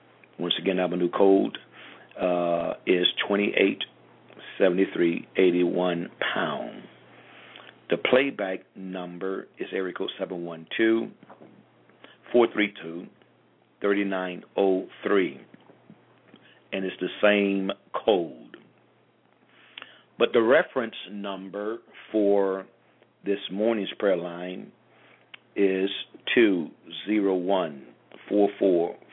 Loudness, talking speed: -26 LUFS, 105 wpm